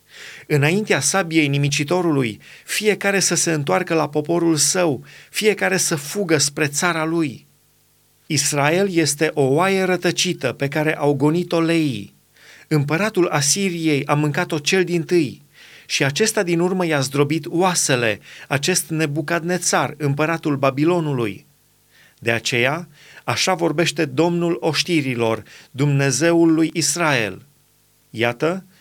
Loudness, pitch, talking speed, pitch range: -19 LUFS, 155 Hz, 110 wpm, 145-175 Hz